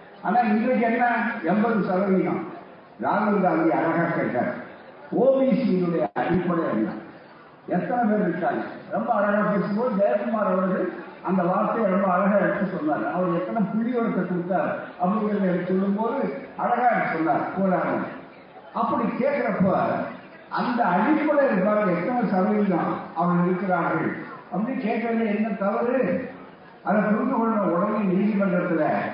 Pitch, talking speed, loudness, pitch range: 200 Hz, 105 wpm, -23 LUFS, 180-230 Hz